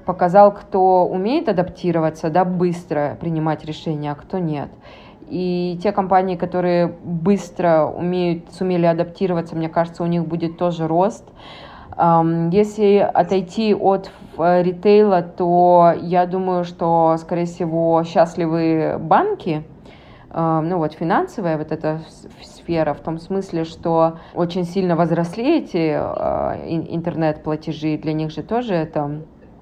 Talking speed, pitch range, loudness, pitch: 120 wpm, 165-185 Hz, -19 LUFS, 175 Hz